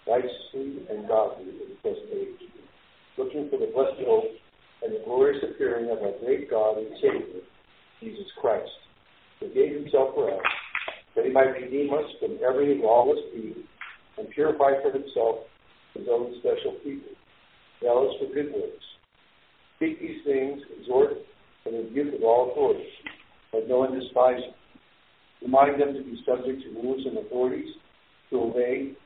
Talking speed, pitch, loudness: 155 wpm, 385 Hz, -26 LUFS